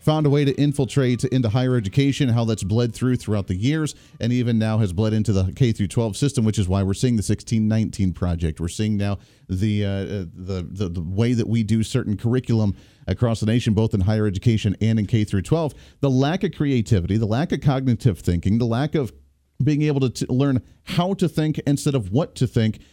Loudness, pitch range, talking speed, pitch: -22 LUFS, 100-135 Hz, 215 wpm, 115 Hz